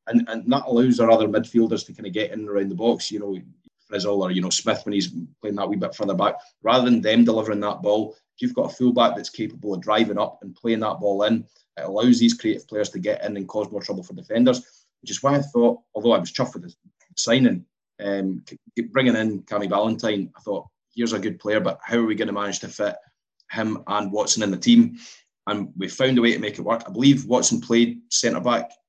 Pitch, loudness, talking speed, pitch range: 115 Hz, -22 LUFS, 245 wpm, 105-135 Hz